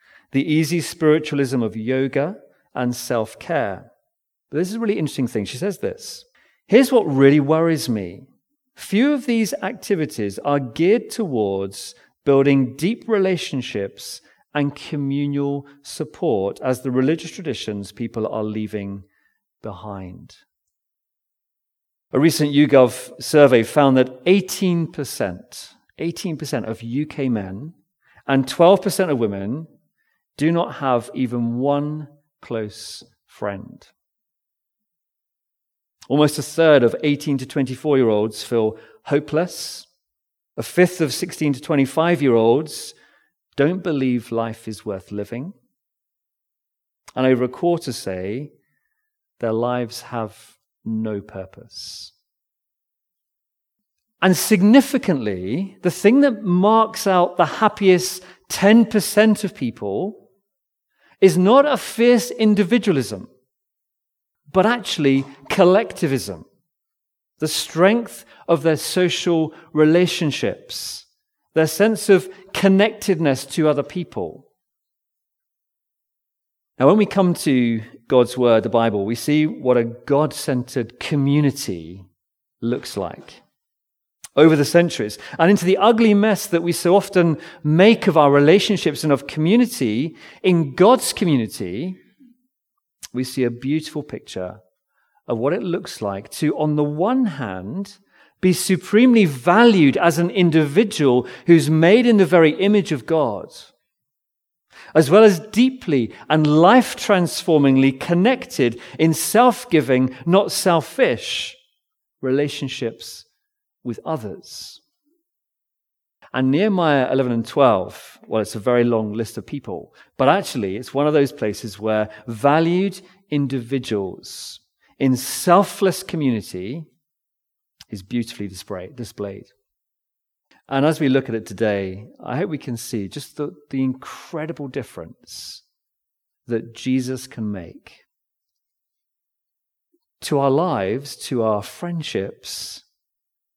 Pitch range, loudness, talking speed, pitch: 125-185 Hz, -19 LUFS, 115 wpm, 150 Hz